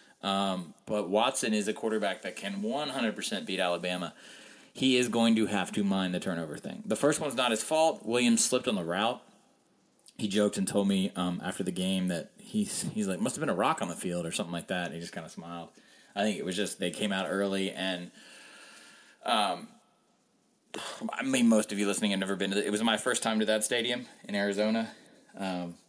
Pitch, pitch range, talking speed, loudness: 105 Hz, 95-125 Hz, 225 wpm, -30 LUFS